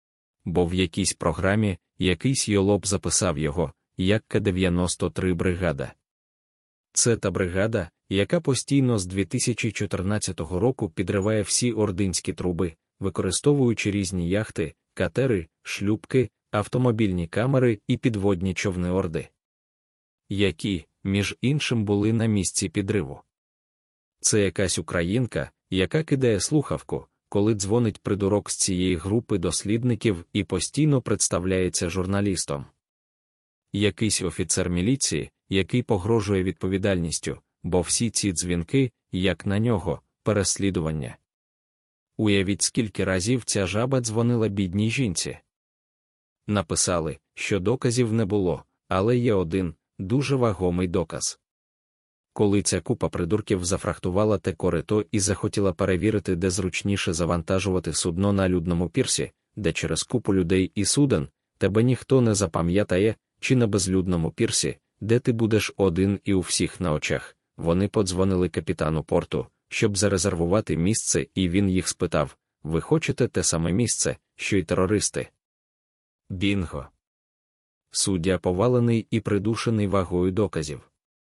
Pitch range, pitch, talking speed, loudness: 90-110 Hz, 100 Hz, 115 wpm, -24 LUFS